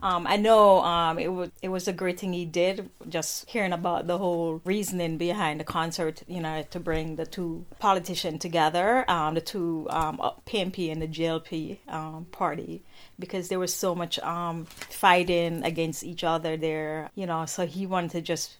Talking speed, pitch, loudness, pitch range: 185 wpm, 170 Hz, -27 LUFS, 160-185 Hz